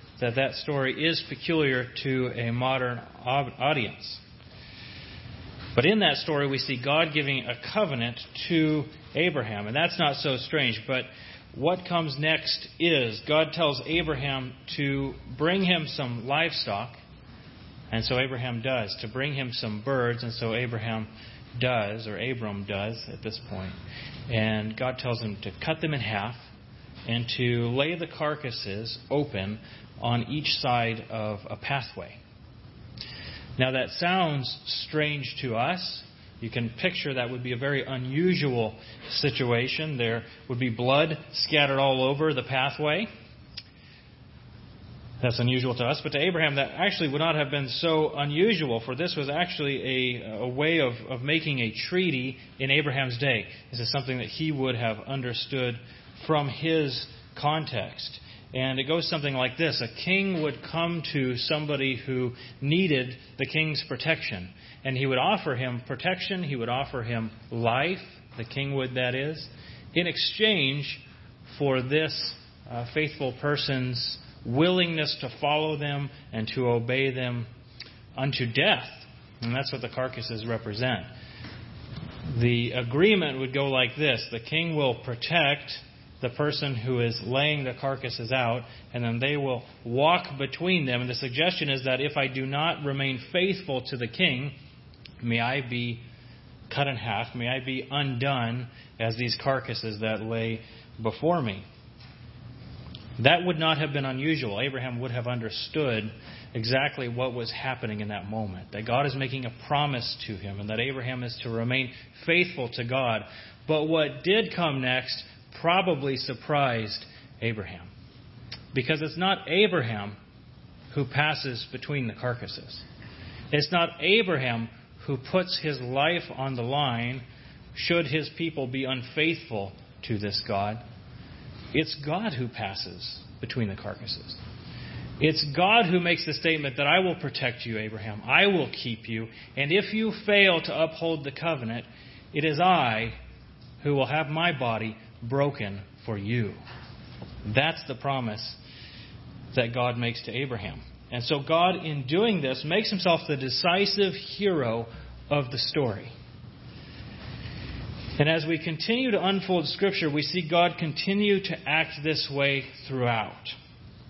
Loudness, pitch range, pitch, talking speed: -27 LUFS, 120-150 Hz, 130 Hz, 150 wpm